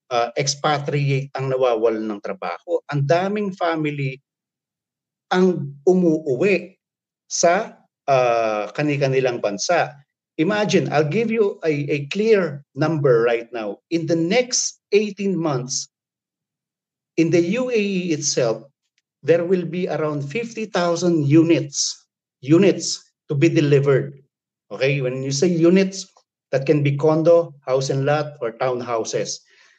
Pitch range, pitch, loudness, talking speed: 135-180 Hz, 155 Hz, -20 LUFS, 120 wpm